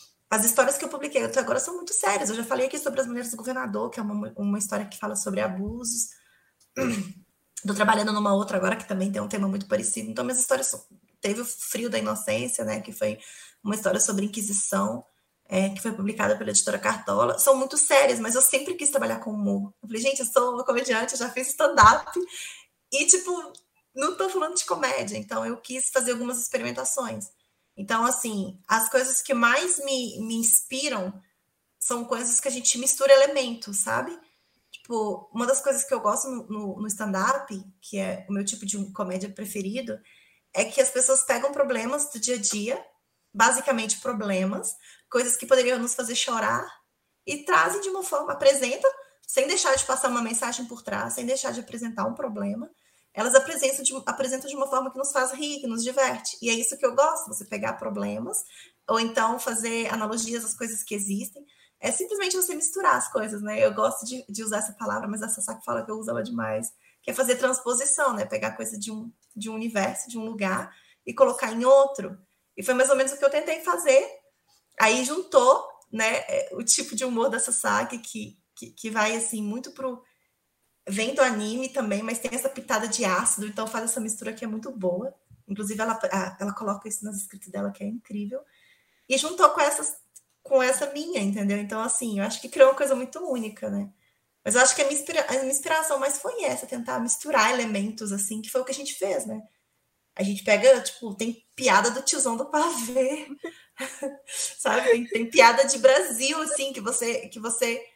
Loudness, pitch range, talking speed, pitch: -25 LUFS, 210-270 Hz, 200 wpm, 245 Hz